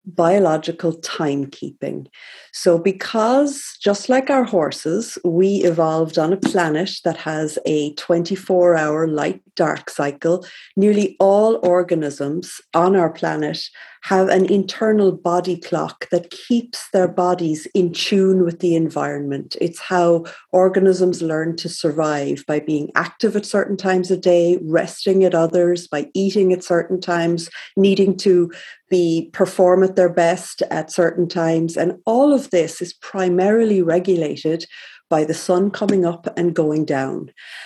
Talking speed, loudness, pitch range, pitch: 140 wpm, -18 LUFS, 165-190 Hz, 175 Hz